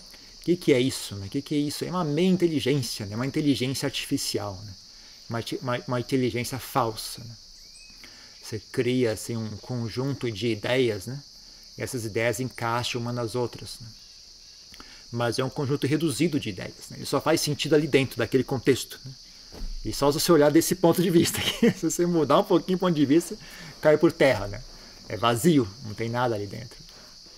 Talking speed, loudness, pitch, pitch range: 195 wpm, -25 LUFS, 130 Hz, 115-150 Hz